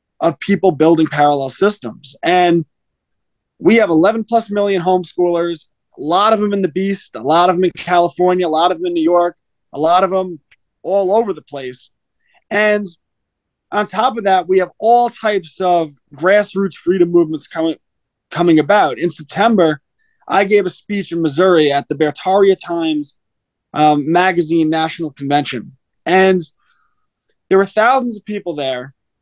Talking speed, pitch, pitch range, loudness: 160 wpm, 175 Hz, 155-195 Hz, -15 LUFS